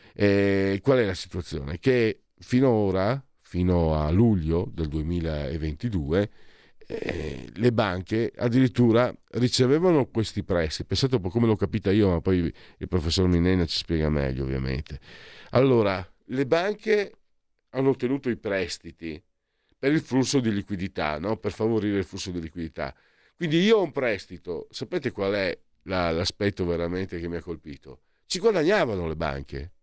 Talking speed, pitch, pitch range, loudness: 150 wpm, 95 Hz, 85-120 Hz, -25 LUFS